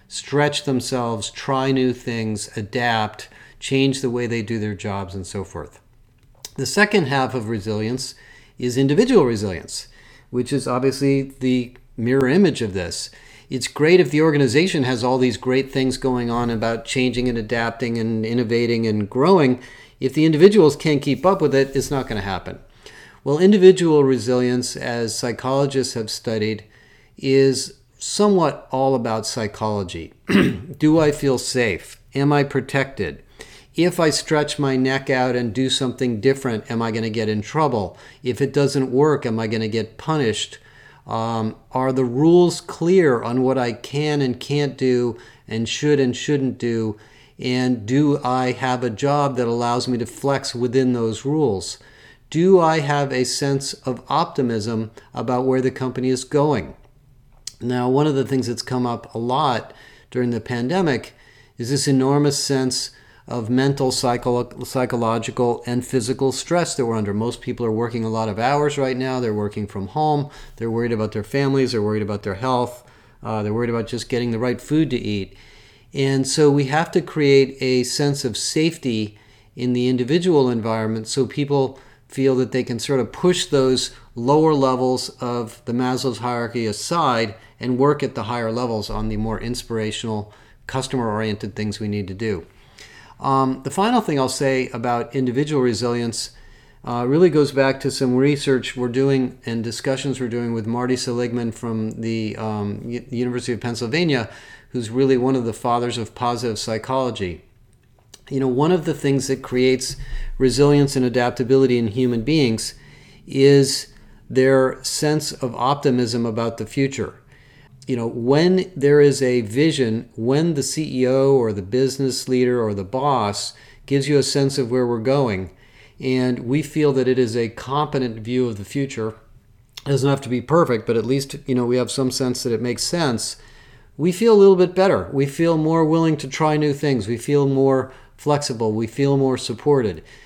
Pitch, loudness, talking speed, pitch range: 130 Hz, -20 LUFS, 175 wpm, 115-140 Hz